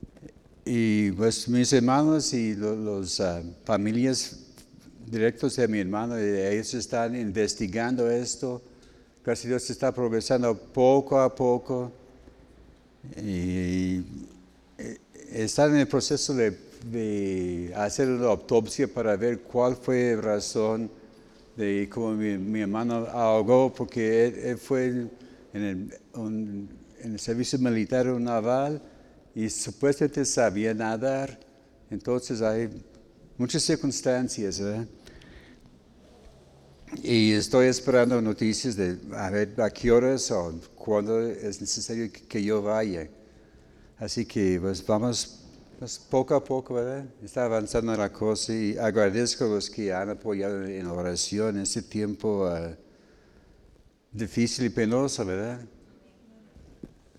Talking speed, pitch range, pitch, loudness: 125 wpm, 105-125 Hz, 115 Hz, -27 LUFS